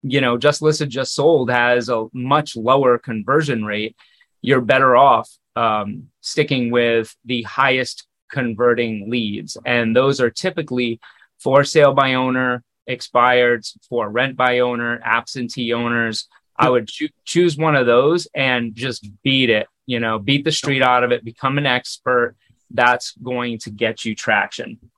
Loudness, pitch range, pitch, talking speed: -18 LUFS, 120-135 Hz, 125 Hz, 155 wpm